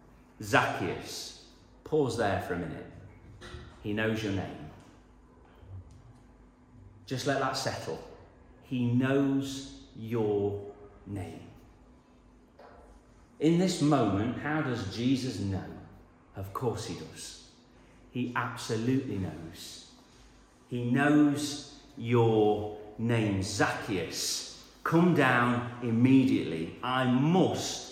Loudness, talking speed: -29 LUFS, 90 wpm